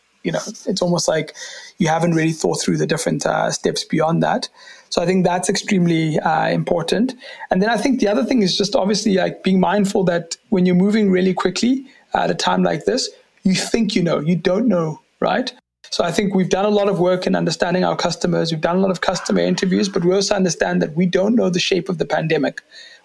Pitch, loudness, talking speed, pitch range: 190 Hz, -18 LUFS, 230 wpm, 180-210 Hz